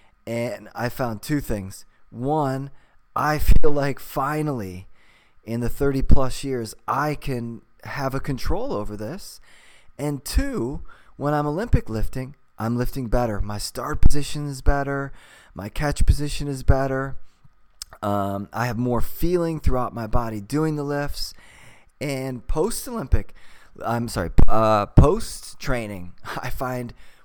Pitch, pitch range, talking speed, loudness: 125 Hz, 110-140 Hz, 135 wpm, -25 LUFS